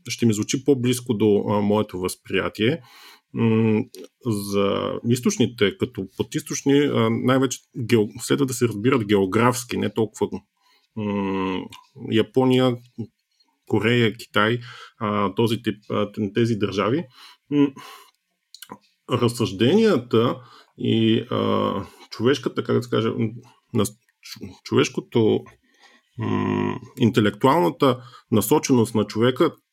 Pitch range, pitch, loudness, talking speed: 105-125 Hz, 115 Hz, -22 LUFS, 100 wpm